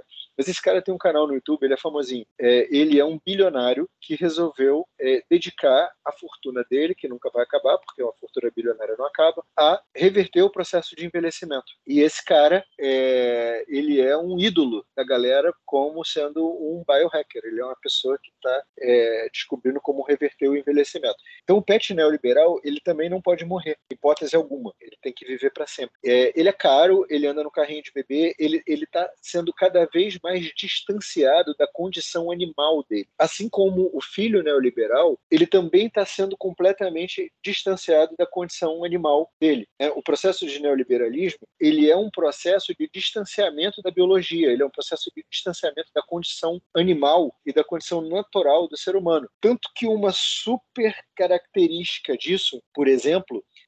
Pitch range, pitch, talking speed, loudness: 150-210 Hz, 175 Hz, 175 wpm, -22 LUFS